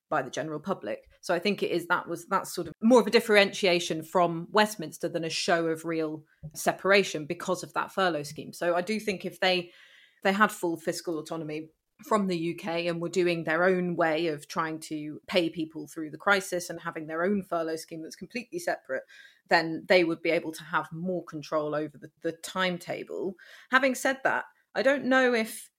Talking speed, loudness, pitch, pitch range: 205 wpm, -28 LUFS, 175 Hz, 160-190 Hz